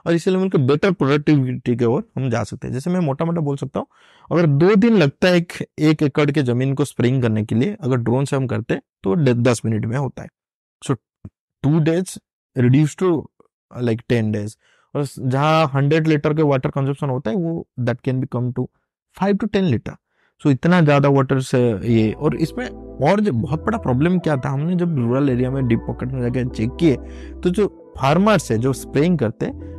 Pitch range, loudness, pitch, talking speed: 125-165 Hz, -19 LUFS, 140 Hz, 200 wpm